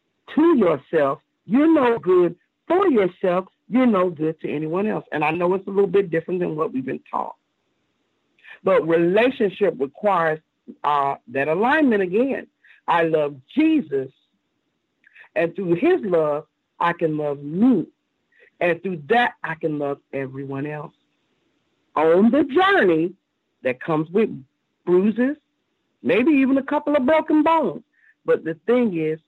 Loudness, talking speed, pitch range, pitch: -21 LUFS, 145 wpm, 160-270 Hz, 190 Hz